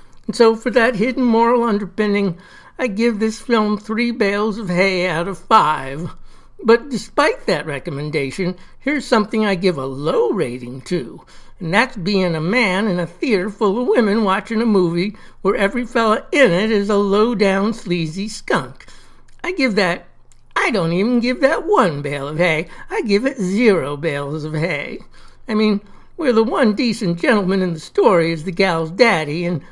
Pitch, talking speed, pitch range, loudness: 205 Hz, 180 wpm, 175-230 Hz, -18 LUFS